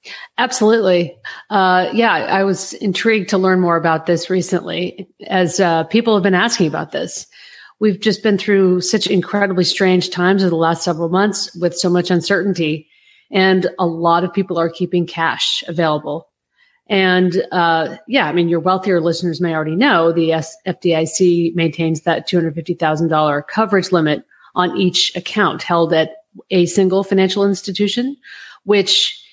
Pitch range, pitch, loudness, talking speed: 170-200 Hz, 180 Hz, -16 LUFS, 150 wpm